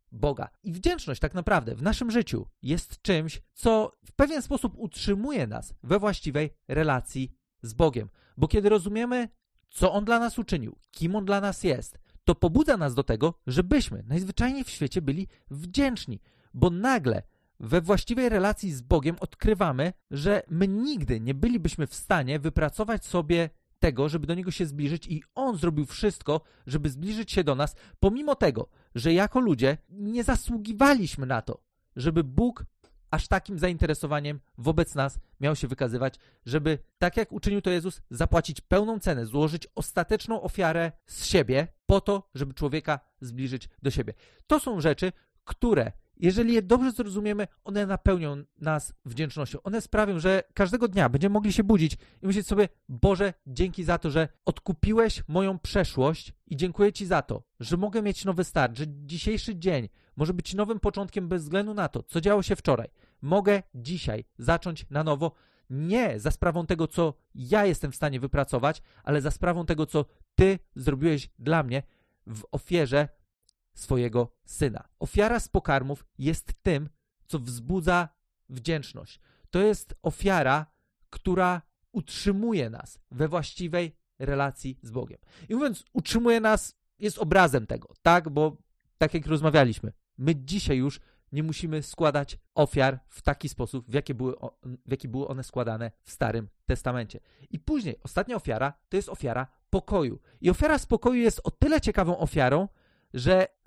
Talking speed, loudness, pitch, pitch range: 155 wpm, -27 LUFS, 165 Hz, 140-200 Hz